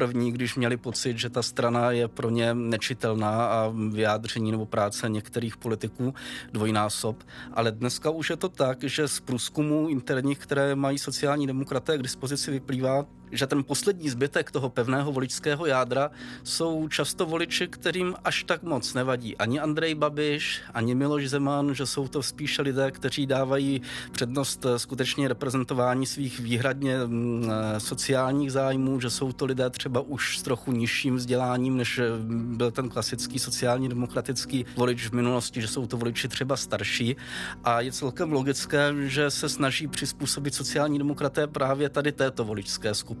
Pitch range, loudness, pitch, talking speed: 120-140 Hz, -27 LUFS, 130 Hz, 155 wpm